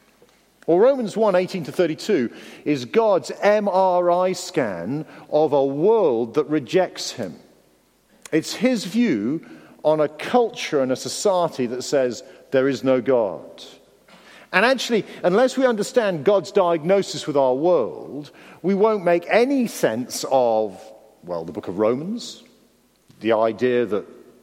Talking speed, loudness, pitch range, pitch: 135 wpm, -21 LUFS, 130-205 Hz, 170 Hz